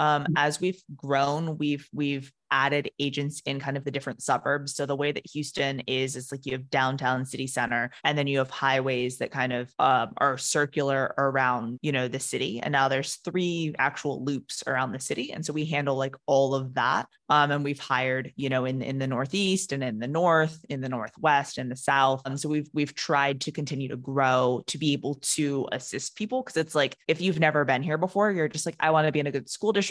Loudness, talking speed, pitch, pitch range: -27 LUFS, 235 wpm, 140 Hz, 135-150 Hz